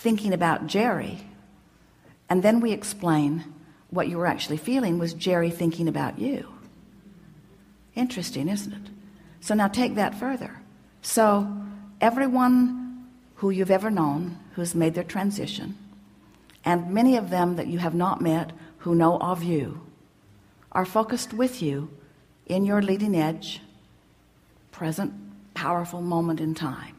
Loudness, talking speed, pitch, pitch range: -25 LUFS, 135 wpm, 175 Hz, 160-210 Hz